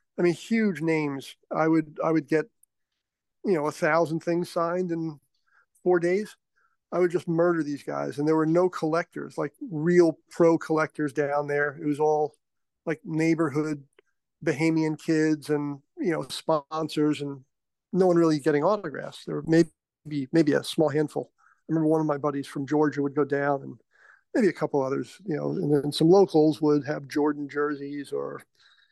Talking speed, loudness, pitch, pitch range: 180 wpm, -26 LUFS, 155 Hz, 145-165 Hz